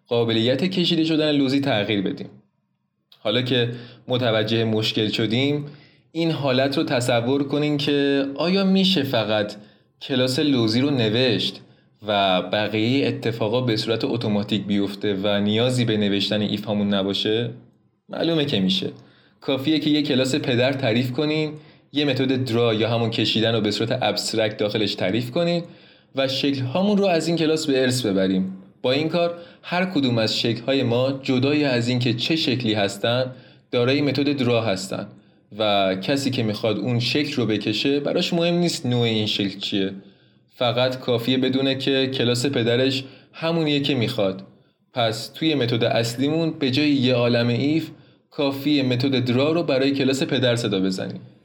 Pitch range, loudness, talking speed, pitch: 110-145 Hz, -21 LUFS, 155 wpm, 125 Hz